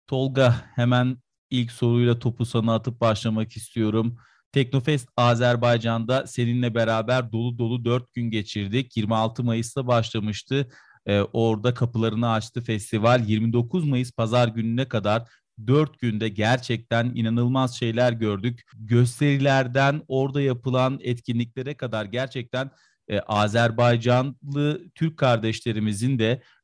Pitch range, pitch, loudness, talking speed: 115-130 Hz, 120 Hz, -24 LUFS, 110 wpm